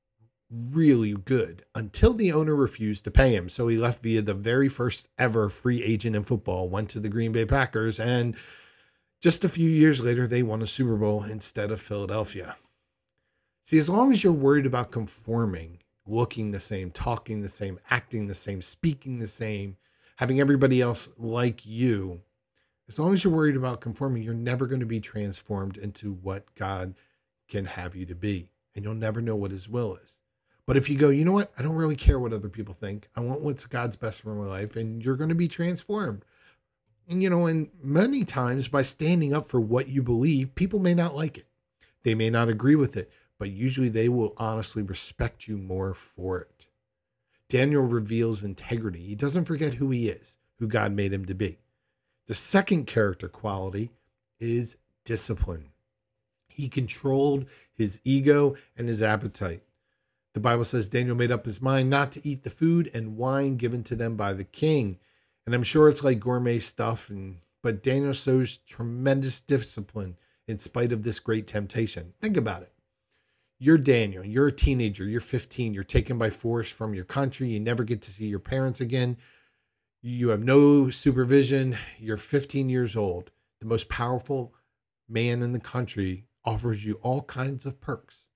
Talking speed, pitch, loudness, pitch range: 185 wpm, 115 Hz, -26 LUFS, 105-135 Hz